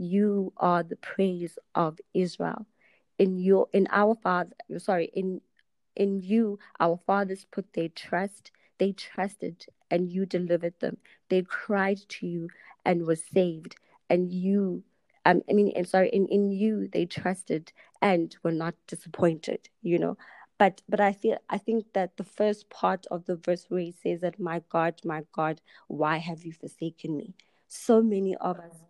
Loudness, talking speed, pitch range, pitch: -28 LUFS, 170 wpm, 170-200 Hz, 185 Hz